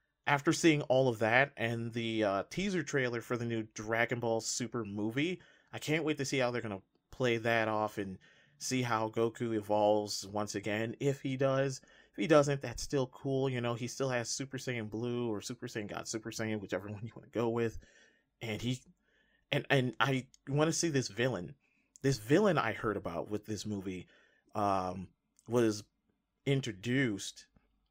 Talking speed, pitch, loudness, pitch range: 185 wpm, 120 Hz, -34 LUFS, 110-135 Hz